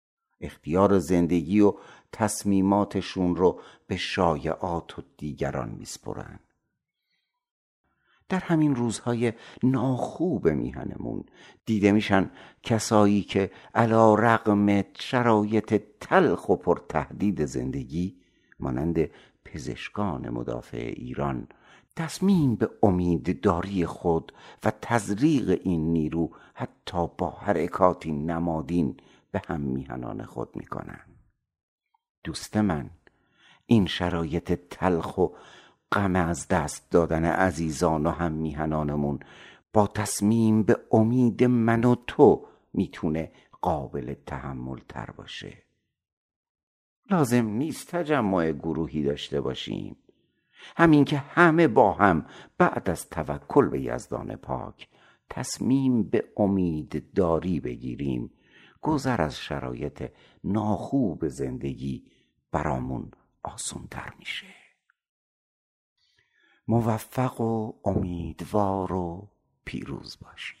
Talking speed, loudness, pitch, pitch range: 95 wpm, -26 LUFS, 100 Hz, 80-115 Hz